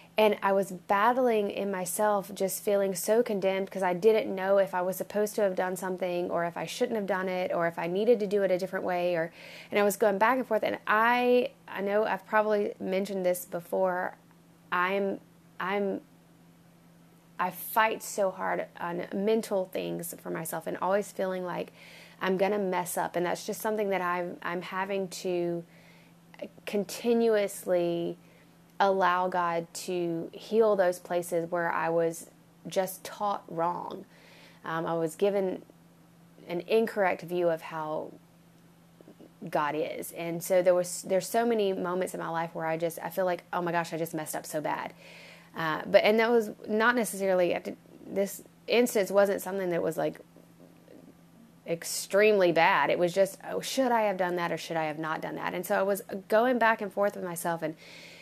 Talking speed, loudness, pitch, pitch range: 185 wpm, -29 LUFS, 185 Hz, 170-205 Hz